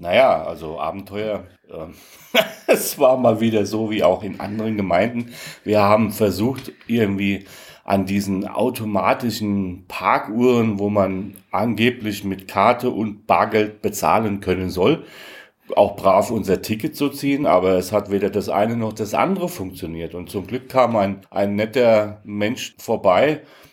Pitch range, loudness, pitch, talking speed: 95-115 Hz, -20 LUFS, 105 Hz, 145 wpm